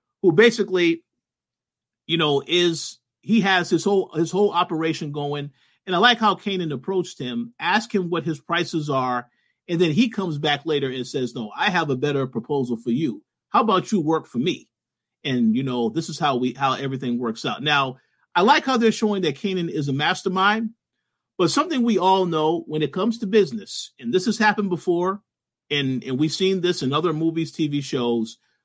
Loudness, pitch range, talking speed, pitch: -22 LUFS, 140-195 Hz, 200 wpm, 165 Hz